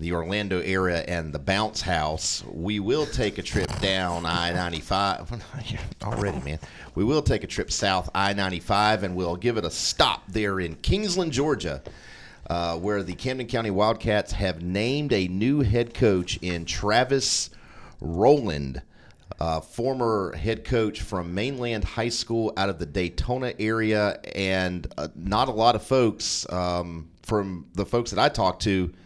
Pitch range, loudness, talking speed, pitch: 90-115 Hz, -25 LUFS, 160 wpm, 100 Hz